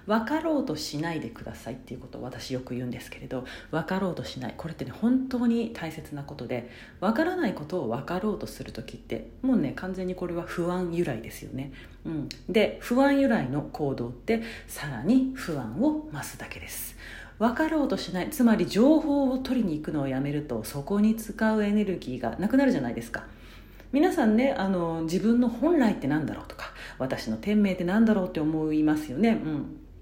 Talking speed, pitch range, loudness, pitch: 400 characters per minute, 150-240 Hz, -27 LUFS, 185 Hz